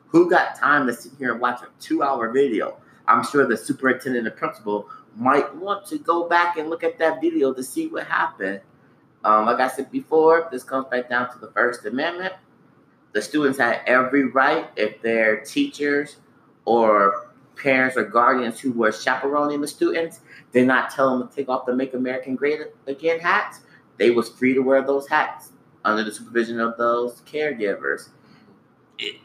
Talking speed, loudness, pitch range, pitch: 180 wpm, -21 LUFS, 120-150 Hz, 130 Hz